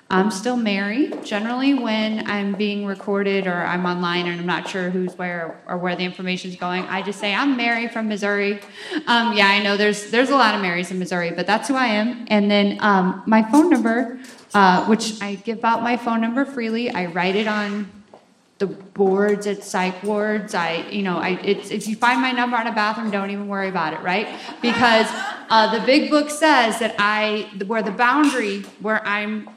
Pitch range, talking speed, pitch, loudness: 195-230 Hz, 205 wpm, 210 Hz, -20 LUFS